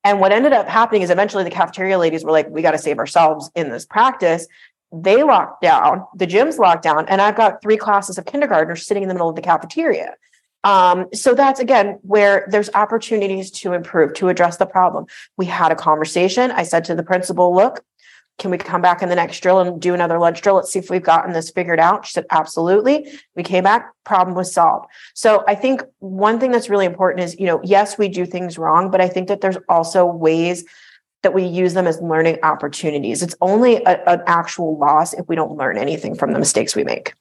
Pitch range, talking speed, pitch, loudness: 170-200 Hz, 225 wpm, 185 Hz, -16 LUFS